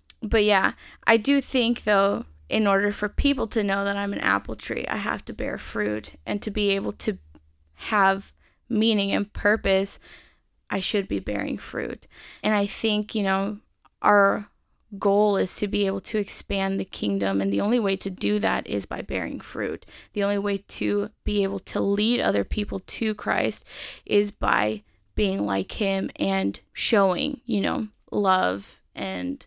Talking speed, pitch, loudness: 175 wpm, 200 Hz, -25 LUFS